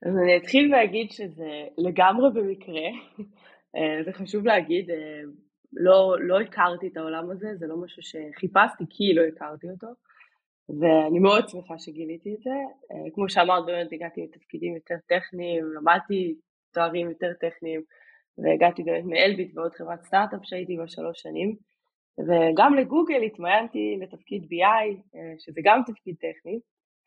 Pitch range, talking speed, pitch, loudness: 165-205 Hz, 130 wpm, 180 Hz, -24 LUFS